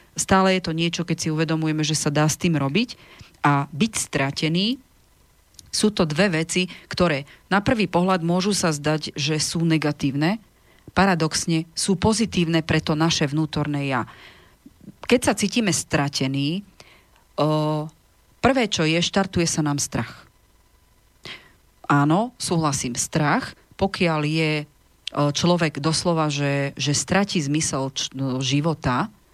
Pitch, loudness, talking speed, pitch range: 160 Hz, -22 LUFS, 125 wpm, 145-180 Hz